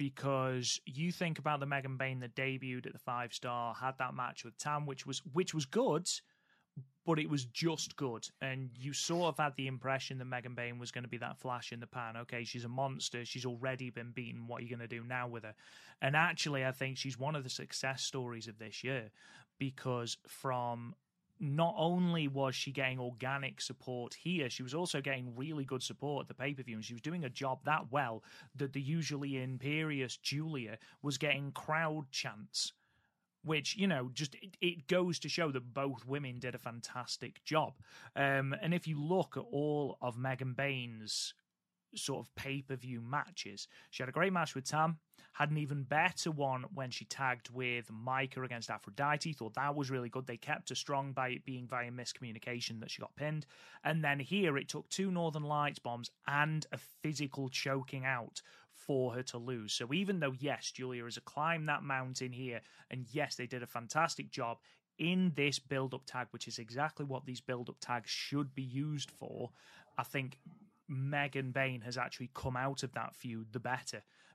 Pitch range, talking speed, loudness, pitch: 125-150 Hz, 200 wpm, -38 LUFS, 135 Hz